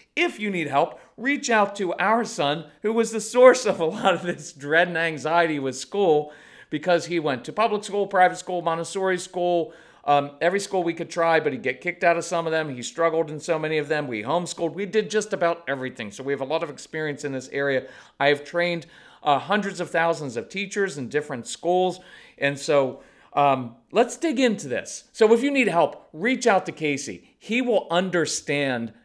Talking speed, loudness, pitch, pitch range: 215 wpm, -24 LUFS, 170 Hz, 145-195 Hz